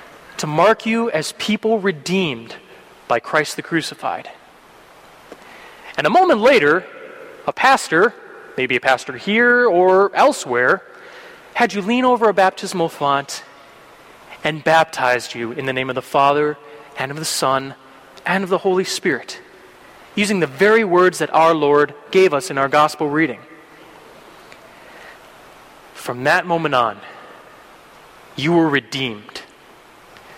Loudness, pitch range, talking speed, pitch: -17 LUFS, 140-205 Hz, 130 wpm, 160 Hz